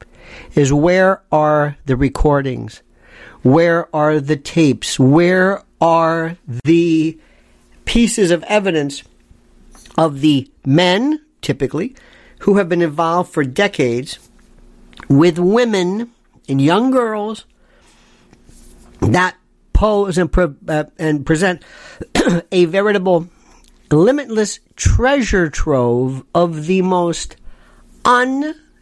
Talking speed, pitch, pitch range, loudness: 95 wpm, 165 Hz, 145-195 Hz, -15 LUFS